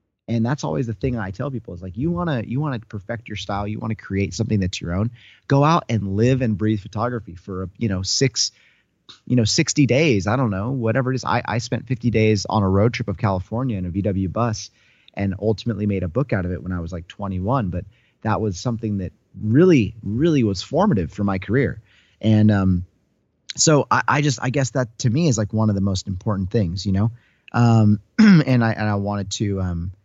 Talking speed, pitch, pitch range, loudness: 230 wpm, 110 Hz, 100-125 Hz, -21 LUFS